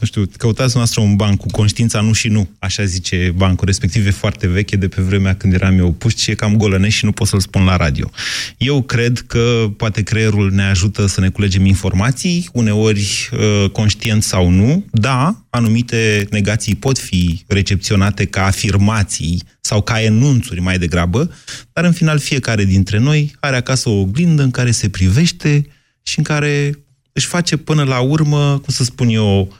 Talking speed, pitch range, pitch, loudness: 180 wpm, 100-130 Hz, 110 Hz, -15 LUFS